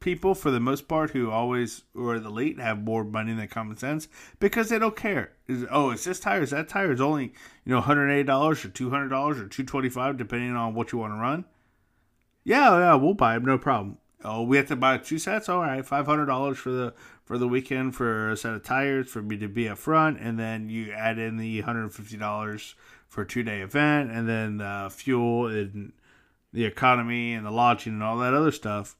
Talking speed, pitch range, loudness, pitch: 215 wpm, 110-140 Hz, -26 LUFS, 120 Hz